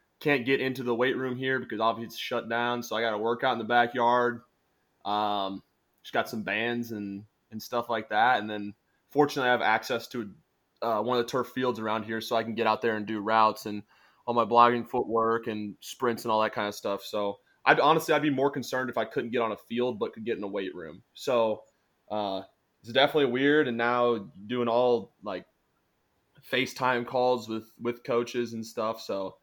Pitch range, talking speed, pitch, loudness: 110-125 Hz, 220 wpm, 120 Hz, -28 LUFS